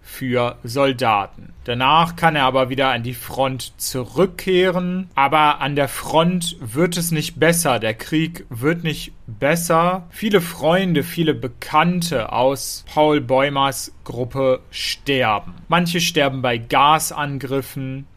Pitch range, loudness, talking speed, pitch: 130-165 Hz, -19 LUFS, 120 wpm, 145 Hz